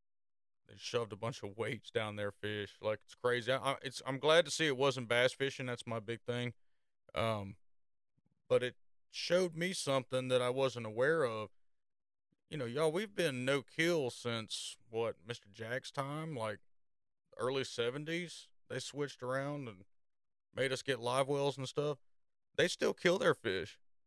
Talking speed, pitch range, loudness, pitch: 170 wpm, 115-140 Hz, -37 LUFS, 130 Hz